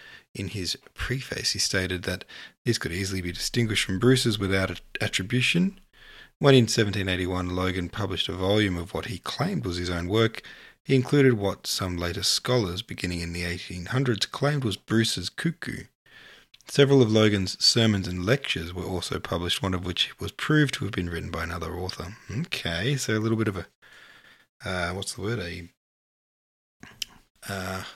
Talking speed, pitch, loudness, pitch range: 165 wpm, 100 Hz, -26 LUFS, 90-120 Hz